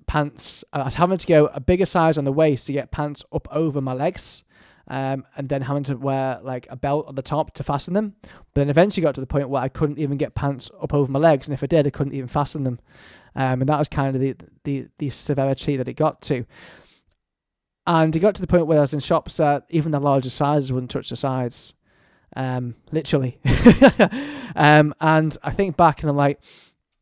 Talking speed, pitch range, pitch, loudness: 230 wpm, 135-155 Hz, 145 Hz, -21 LUFS